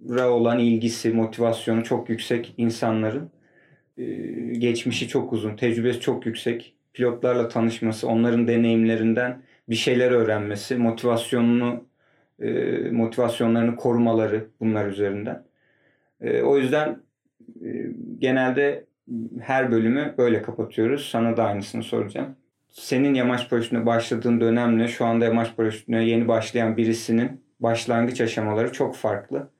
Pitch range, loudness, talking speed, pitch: 115-120 Hz, -23 LUFS, 105 wpm, 115 Hz